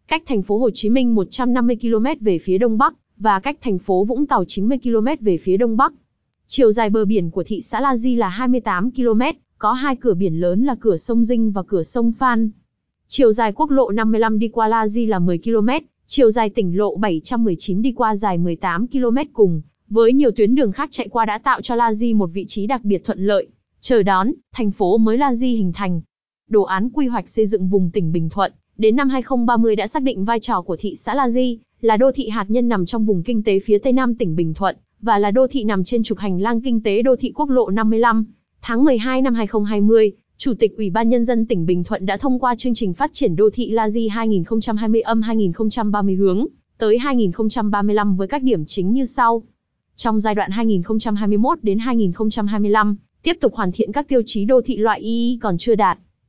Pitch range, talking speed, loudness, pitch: 205-245 Hz, 225 wpm, -18 LUFS, 225 Hz